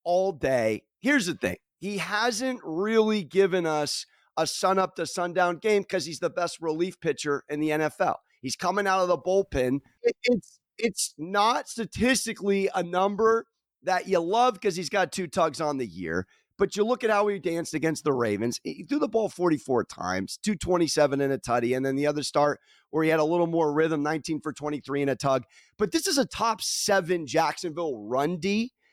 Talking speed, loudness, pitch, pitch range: 195 wpm, -26 LUFS, 175 Hz, 150-205 Hz